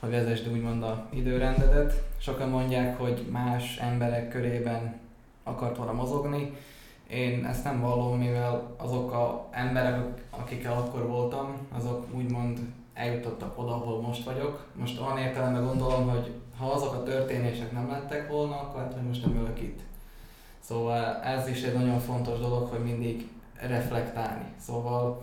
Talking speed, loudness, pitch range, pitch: 145 wpm, -31 LUFS, 120-130 Hz, 120 Hz